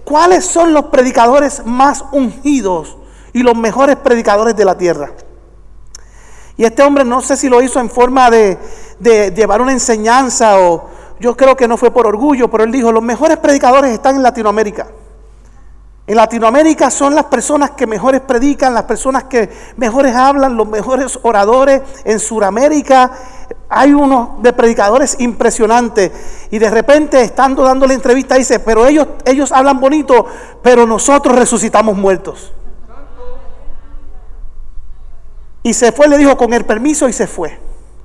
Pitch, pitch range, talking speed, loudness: 255 Hz, 230-275 Hz, 150 wpm, -10 LUFS